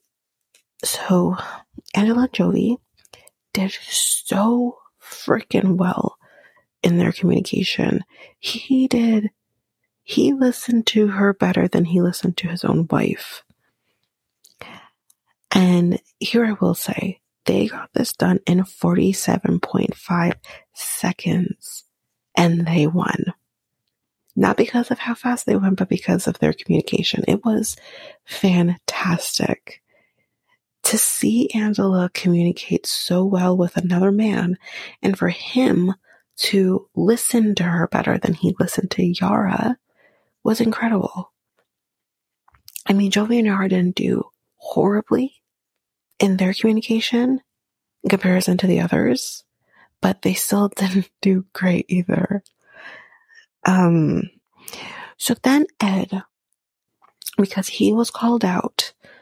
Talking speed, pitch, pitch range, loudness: 110 wpm, 200 Hz, 185-230 Hz, -20 LUFS